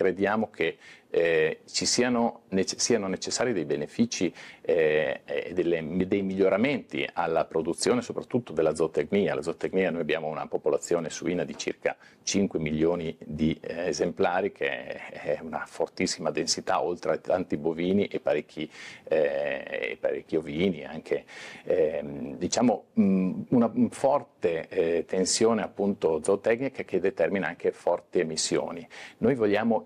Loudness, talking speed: -27 LUFS, 130 wpm